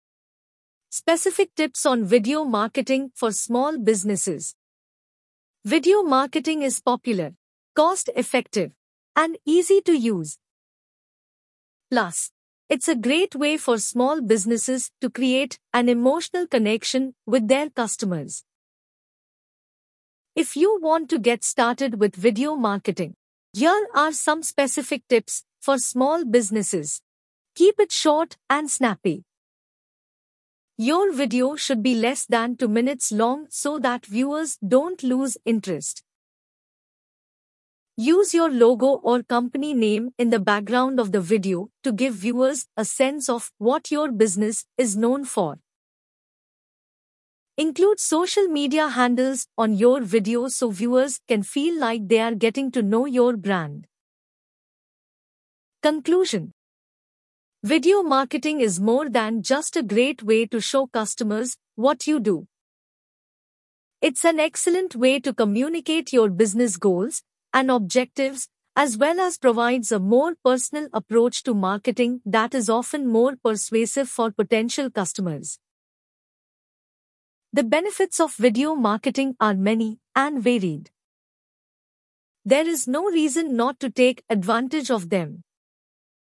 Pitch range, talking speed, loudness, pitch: 225-290 Hz, 125 wpm, -22 LUFS, 250 Hz